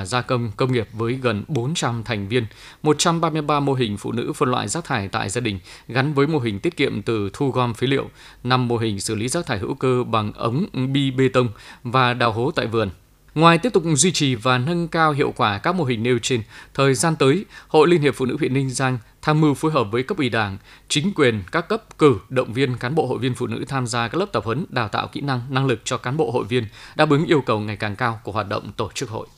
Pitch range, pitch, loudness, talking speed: 115-150 Hz, 130 Hz, -21 LUFS, 260 wpm